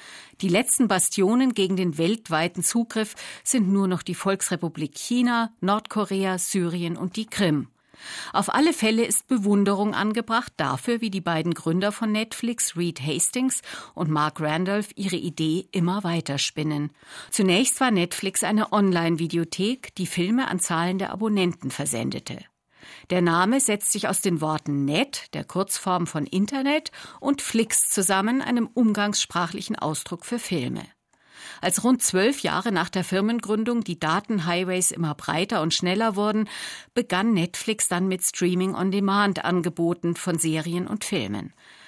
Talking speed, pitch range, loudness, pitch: 140 wpm, 170-220 Hz, -24 LUFS, 190 Hz